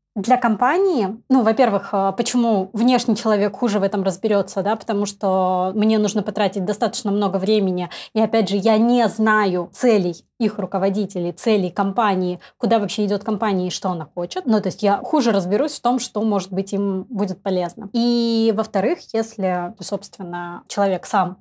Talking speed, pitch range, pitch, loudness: 165 wpm, 190-225 Hz, 205 Hz, -20 LUFS